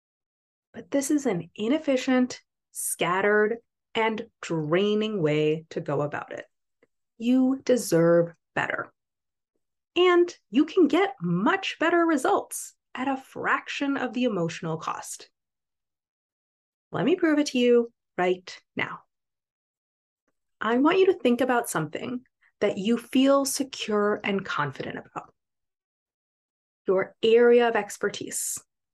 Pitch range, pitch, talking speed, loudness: 175-270 Hz, 235 Hz, 115 wpm, -25 LUFS